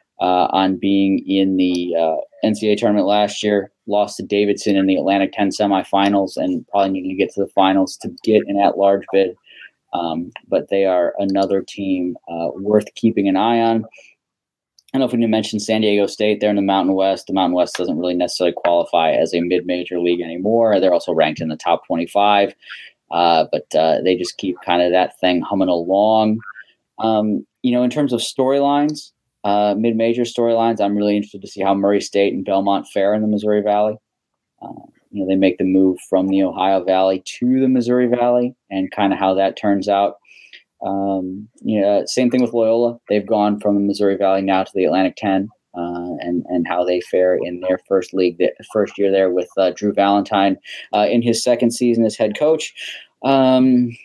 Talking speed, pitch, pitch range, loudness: 200 wpm, 100 Hz, 95-110 Hz, -18 LUFS